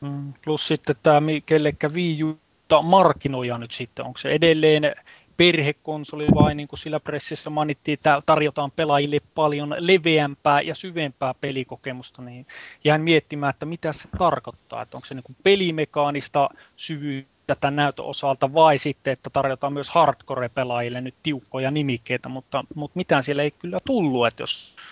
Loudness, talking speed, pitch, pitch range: -22 LUFS, 145 wpm, 145 Hz, 140-155 Hz